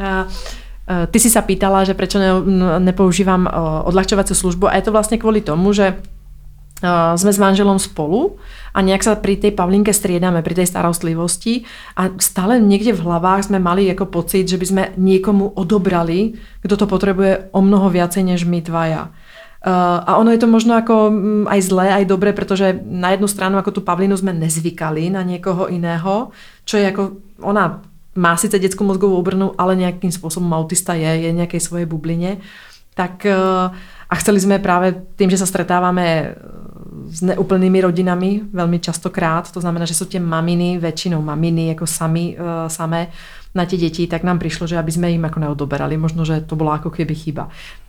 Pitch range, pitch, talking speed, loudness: 170-195 Hz, 185 Hz, 170 wpm, -16 LUFS